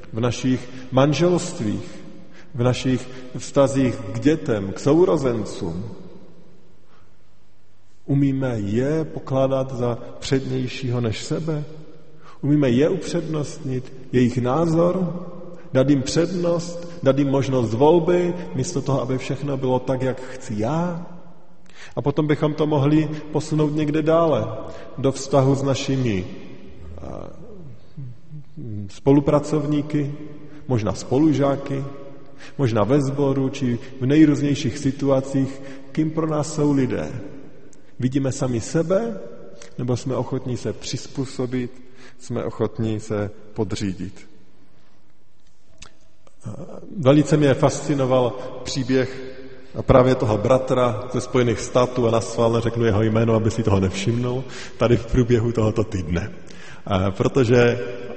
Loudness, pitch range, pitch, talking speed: -21 LUFS, 120-150 Hz, 130 Hz, 105 wpm